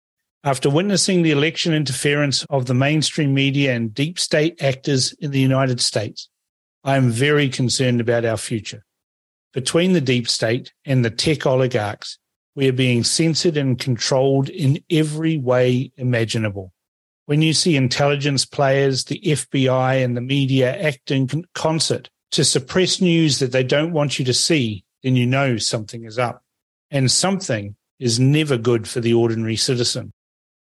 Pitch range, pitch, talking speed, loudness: 120-150 Hz, 135 Hz, 155 wpm, -19 LUFS